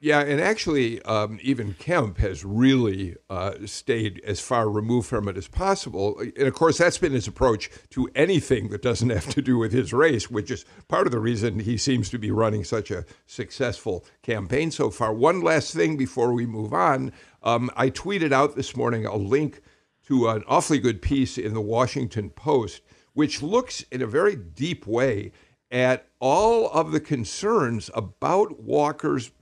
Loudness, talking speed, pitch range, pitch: -24 LUFS, 180 wpm, 105-135 Hz, 120 Hz